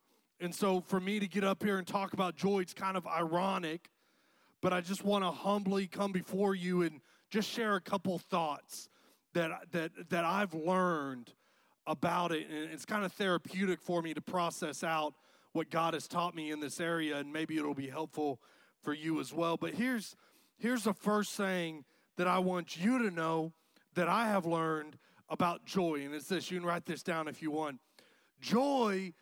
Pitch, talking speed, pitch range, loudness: 175 Hz, 195 wpm, 160-195 Hz, -35 LUFS